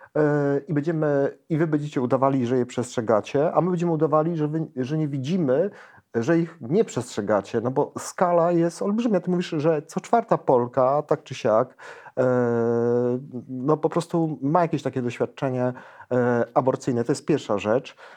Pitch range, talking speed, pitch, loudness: 125-165 Hz, 160 wpm, 145 Hz, -24 LUFS